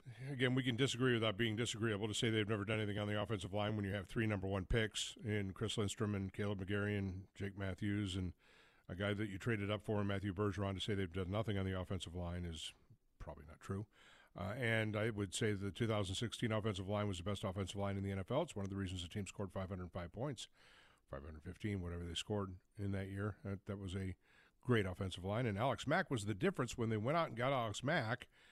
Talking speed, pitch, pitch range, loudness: 235 wpm, 105 Hz, 95-110 Hz, -41 LUFS